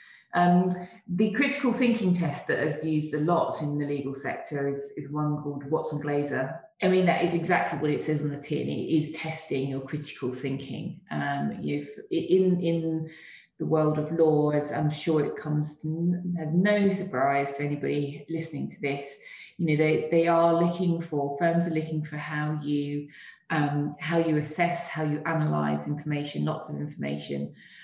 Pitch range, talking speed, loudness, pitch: 145-170 Hz, 175 wpm, -28 LUFS, 150 Hz